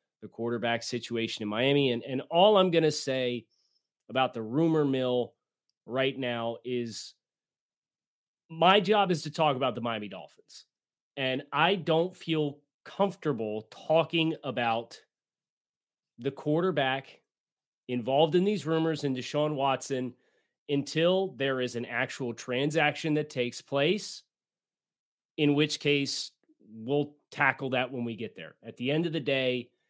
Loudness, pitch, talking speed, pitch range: -29 LUFS, 135 Hz, 140 wpm, 125-160 Hz